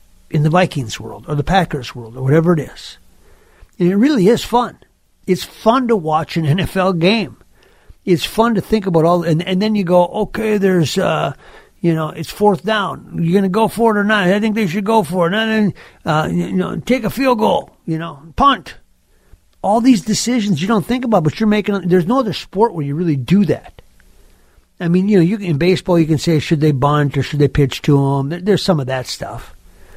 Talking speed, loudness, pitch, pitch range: 230 wpm, -16 LUFS, 180 Hz, 155-210 Hz